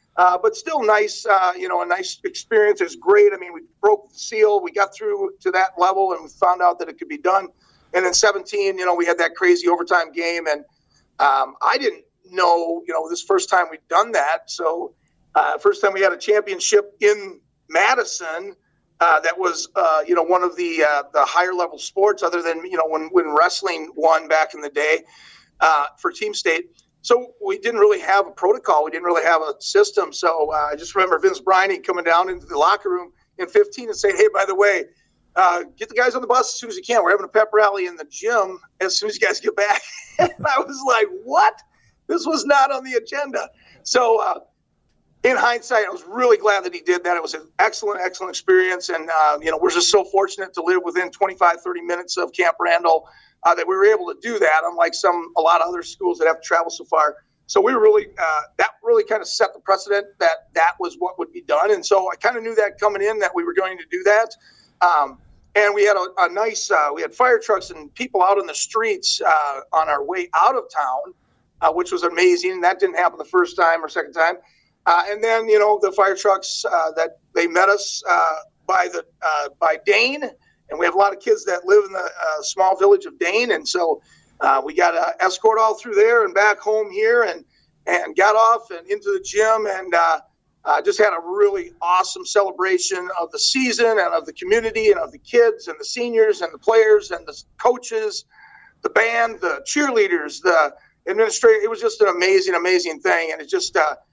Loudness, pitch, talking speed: -19 LUFS, 210 Hz, 230 wpm